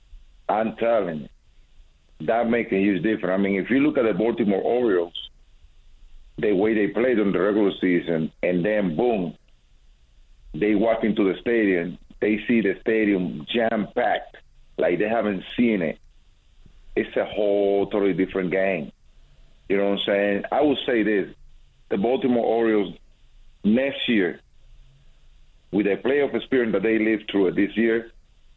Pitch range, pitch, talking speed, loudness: 75-105 Hz, 95 Hz, 160 wpm, -23 LUFS